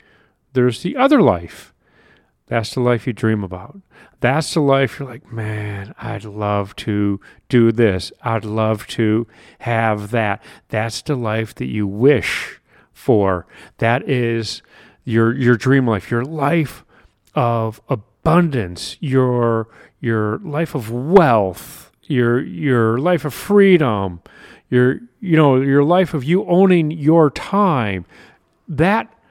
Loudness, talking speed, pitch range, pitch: -18 LUFS, 130 wpm, 110-145 Hz, 120 Hz